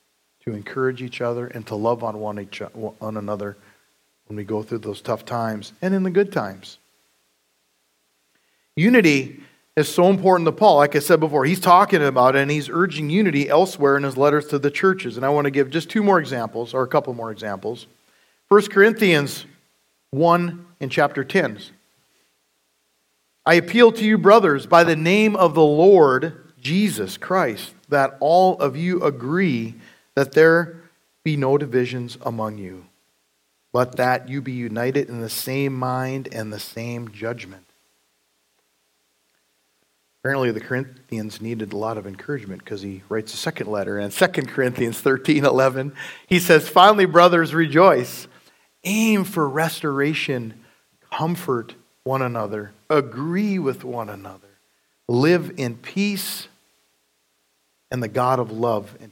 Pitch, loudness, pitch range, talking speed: 130 Hz, -19 LUFS, 105-160 Hz, 150 wpm